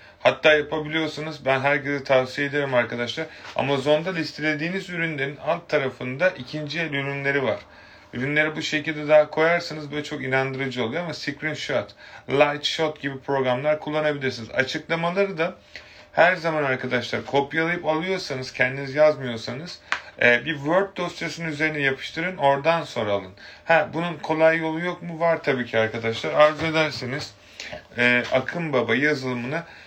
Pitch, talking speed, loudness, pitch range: 150 Hz, 130 wpm, -23 LUFS, 135-160 Hz